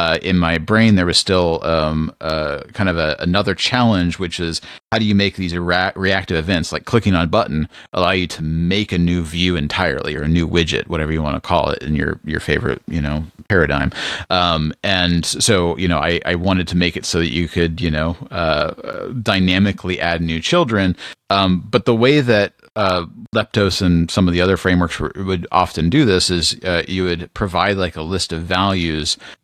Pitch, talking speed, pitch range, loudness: 90 Hz, 210 wpm, 85-95 Hz, -17 LUFS